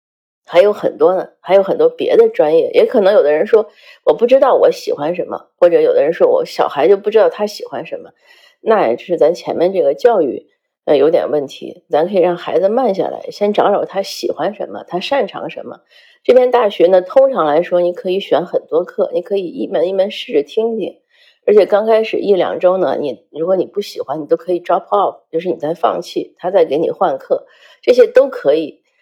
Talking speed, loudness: 320 characters per minute, -14 LUFS